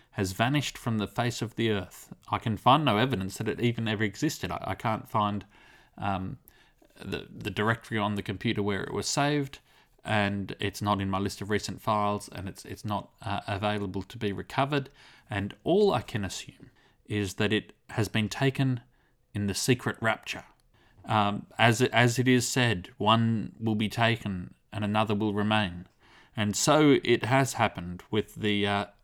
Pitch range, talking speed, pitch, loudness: 100-120 Hz, 185 wpm, 110 Hz, -28 LUFS